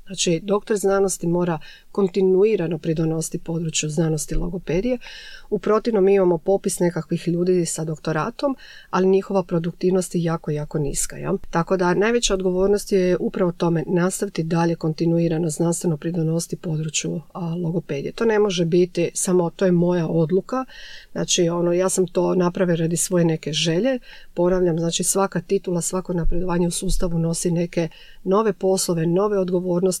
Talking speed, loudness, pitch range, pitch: 145 wpm, -21 LUFS, 170-190 Hz, 175 Hz